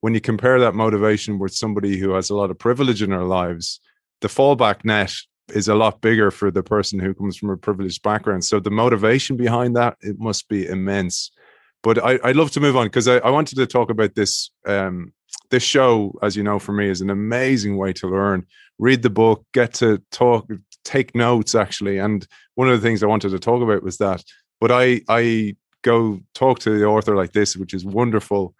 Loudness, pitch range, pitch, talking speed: -19 LUFS, 100-120 Hz, 105 Hz, 220 wpm